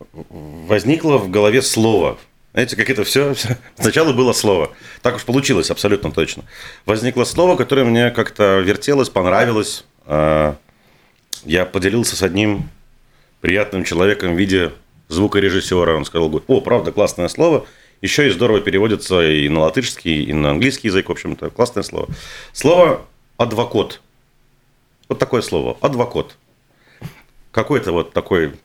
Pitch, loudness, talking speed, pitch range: 100 Hz, -16 LUFS, 130 wpm, 80-125 Hz